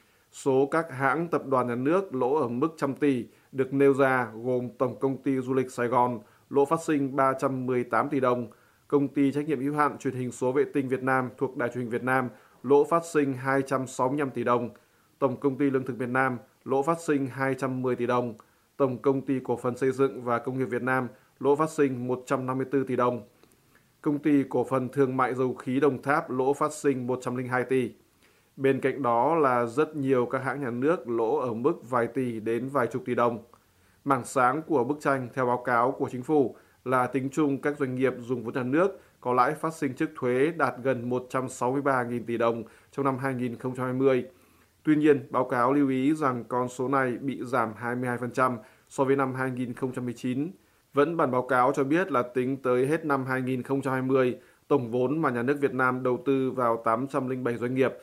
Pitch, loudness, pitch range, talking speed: 130 Hz, -27 LUFS, 125-140 Hz, 205 wpm